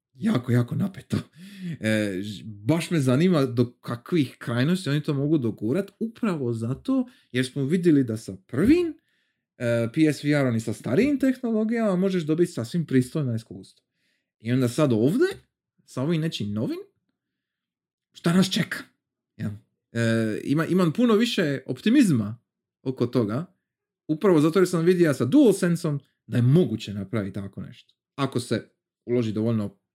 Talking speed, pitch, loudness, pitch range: 140 wpm, 140 Hz, -24 LUFS, 120-185 Hz